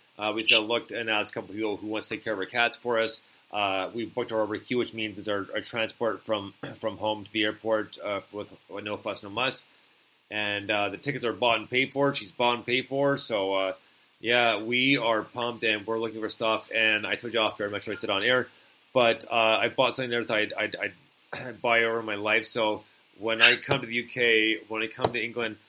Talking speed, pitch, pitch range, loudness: 255 wpm, 110 Hz, 105-120 Hz, -27 LUFS